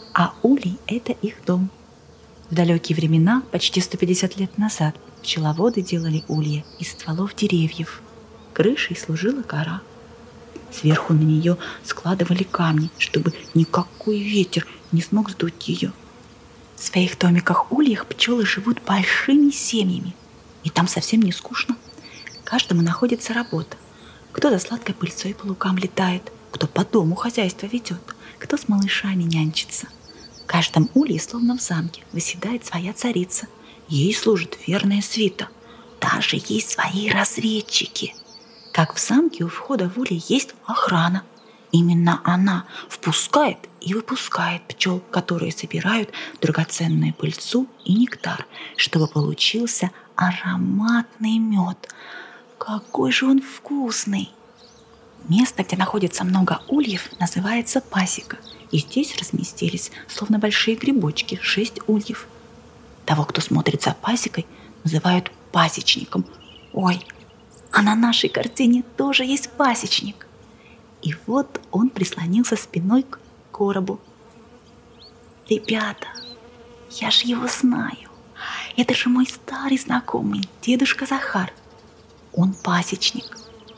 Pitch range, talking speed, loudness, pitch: 180-235 Hz, 115 wpm, -21 LUFS, 205 Hz